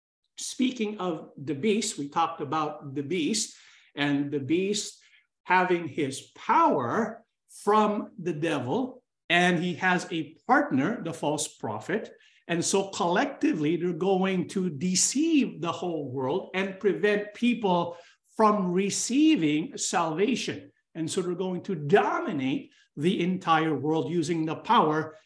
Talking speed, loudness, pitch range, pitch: 130 wpm, -27 LUFS, 160-215 Hz, 180 Hz